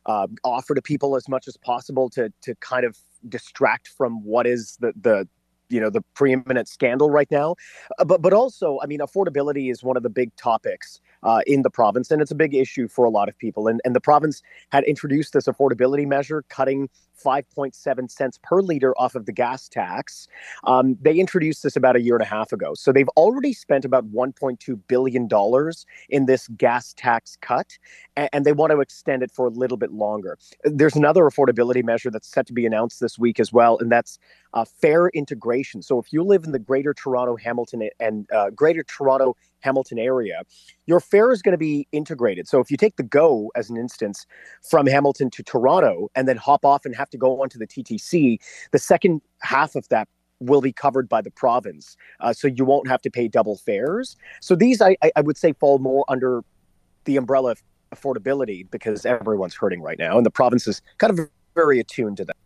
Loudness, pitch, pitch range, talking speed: -20 LUFS, 135 Hz, 120-150 Hz, 210 wpm